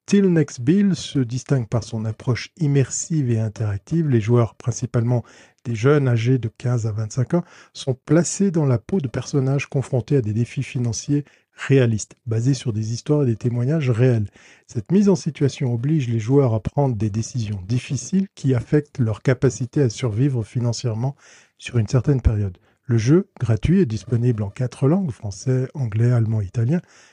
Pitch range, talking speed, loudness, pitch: 115-145 Hz, 175 wpm, -21 LUFS, 125 Hz